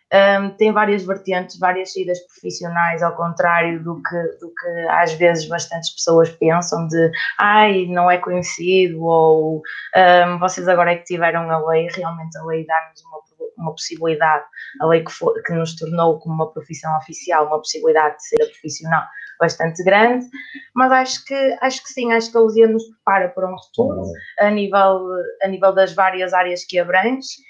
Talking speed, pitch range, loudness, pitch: 175 wpm, 165-195 Hz, -17 LUFS, 175 Hz